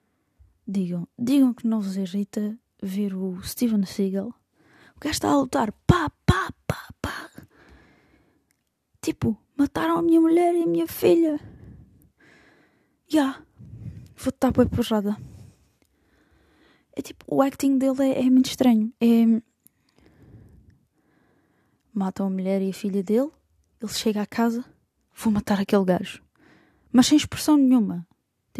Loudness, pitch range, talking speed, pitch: -23 LUFS, 200-270 Hz, 125 wpm, 230 Hz